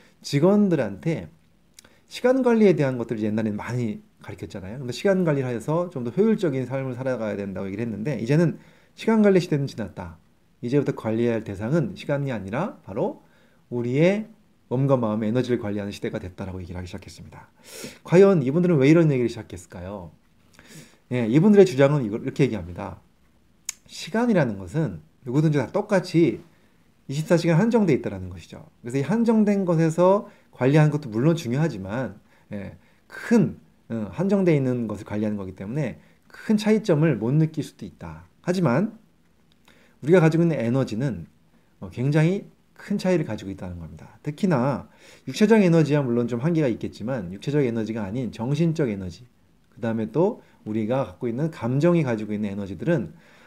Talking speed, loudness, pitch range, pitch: 375 characters per minute, -23 LUFS, 110-170 Hz, 135 Hz